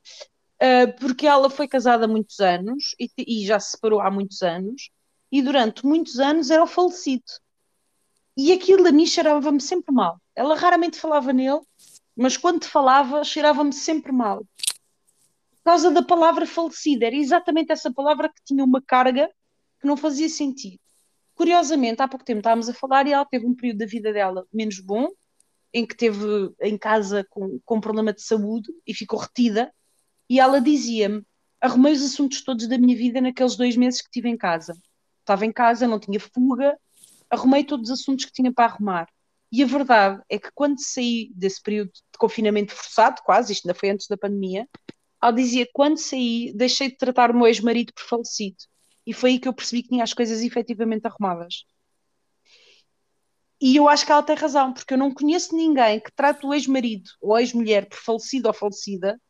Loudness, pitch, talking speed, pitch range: -21 LUFS, 250 Hz, 185 wpm, 220-285 Hz